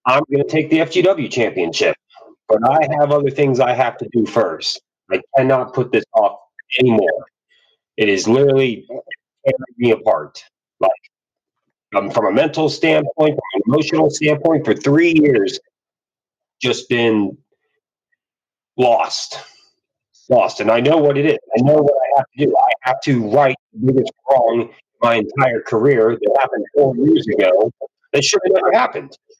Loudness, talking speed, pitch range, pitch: -16 LUFS, 160 wpm, 130-160 Hz, 145 Hz